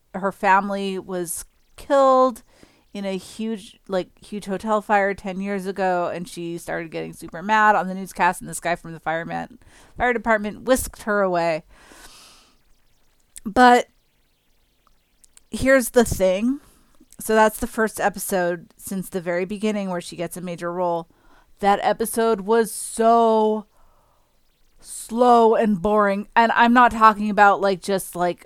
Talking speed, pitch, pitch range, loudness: 145 wpm, 200 Hz, 185-225 Hz, -21 LUFS